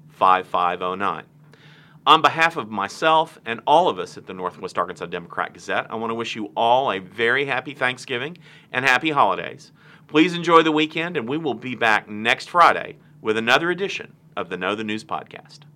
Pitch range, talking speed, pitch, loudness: 115-155 Hz, 185 wpm, 145 Hz, -21 LUFS